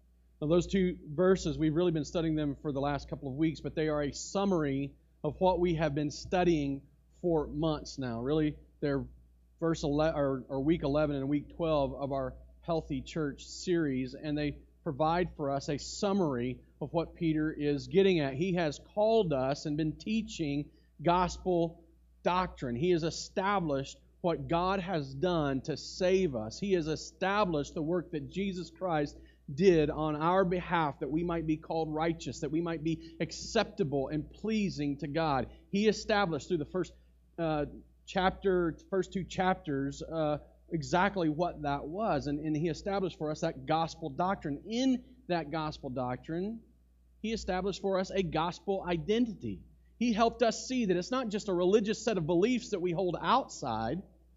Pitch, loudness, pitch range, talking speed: 160 Hz, -32 LUFS, 145-185 Hz, 170 wpm